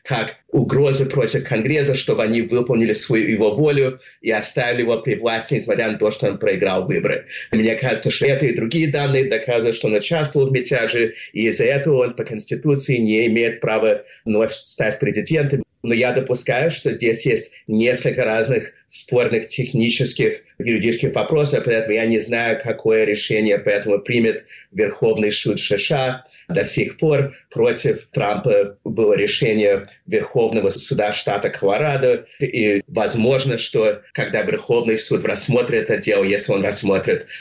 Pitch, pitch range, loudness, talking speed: 130 Hz, 115-160 Hz, -19 LUFS, 150 wpm